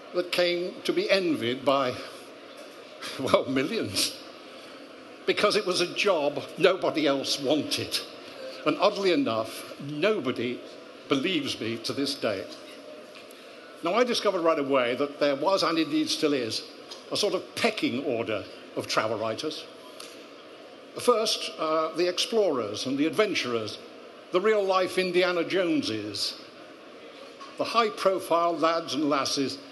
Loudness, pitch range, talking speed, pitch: -27 LUFS, 160-220 Hz, 125 wpm, 180 Hz